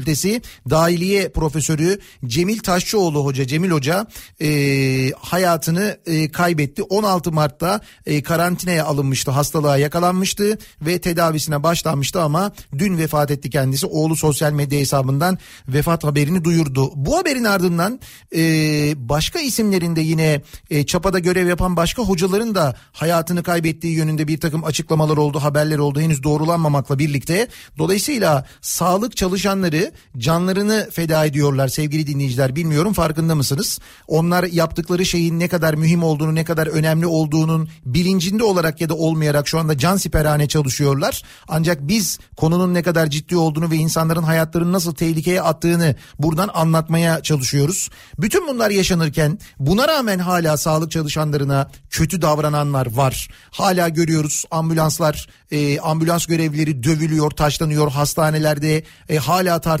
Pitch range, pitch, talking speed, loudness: 150-175 Hz, 160 Hz, 130 wpm, -18 LUFS